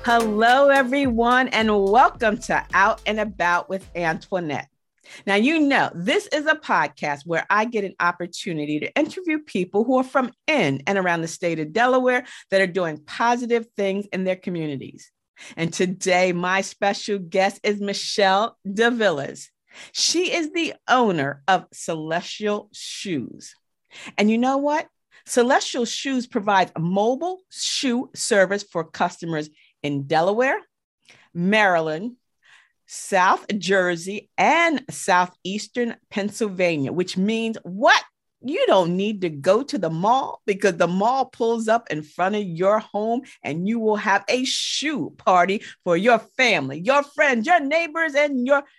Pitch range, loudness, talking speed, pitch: 180-250 Hz, -21 LUFS, 145 wpm, 210 Hz